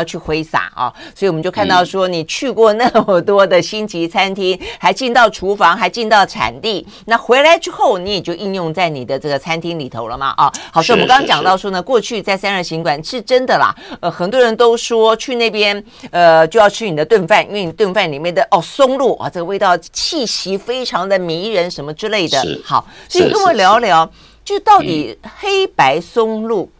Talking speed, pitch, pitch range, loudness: 310 characters per minute, 200 Hz, 175-235 Hz, -14 LUFS